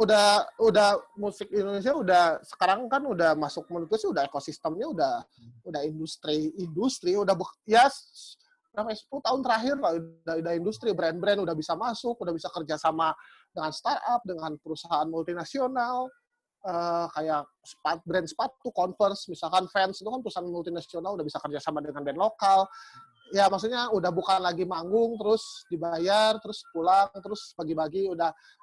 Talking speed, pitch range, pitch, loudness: 150 wpm, 165-220 Hz, 185 Hz, -28 LUFS